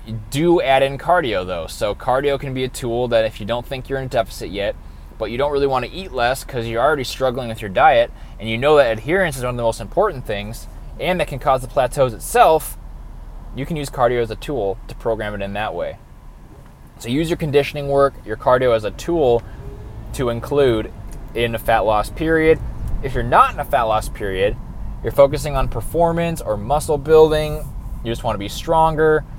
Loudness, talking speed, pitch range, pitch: -19 LUFS, 215 wpm, 110-145 Hz, 130 Hz